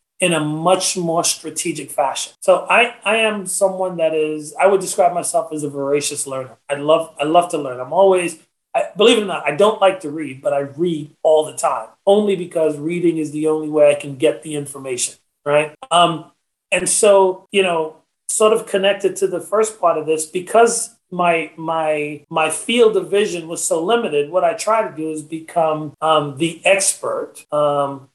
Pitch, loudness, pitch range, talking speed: 165 Hz, -17 LUFS, 150-195 Hz, 200 wpm